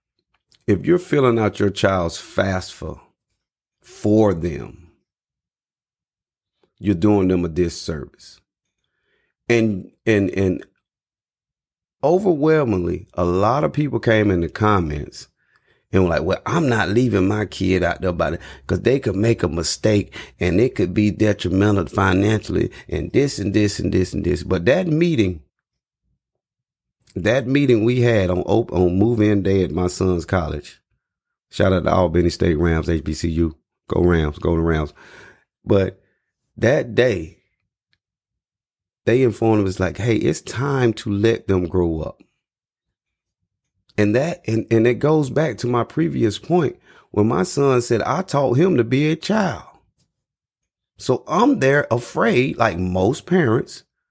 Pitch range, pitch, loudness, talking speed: 90-120 Hz, 105 Hz, -19 LUFS, 145 wpm